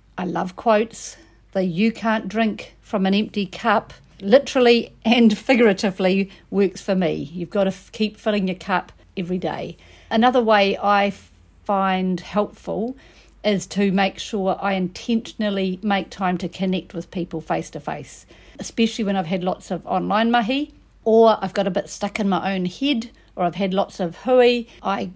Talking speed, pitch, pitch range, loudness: 175 wpm, 200 Hz, 185-220 Hz, -21 LUFS